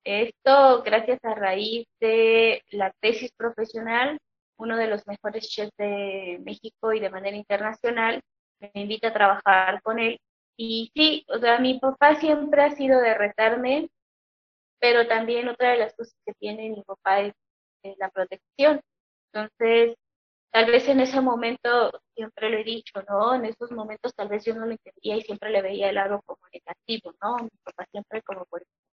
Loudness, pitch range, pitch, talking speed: -23 LUFS, 205-240 Hz, 225 Hz, 170 wpm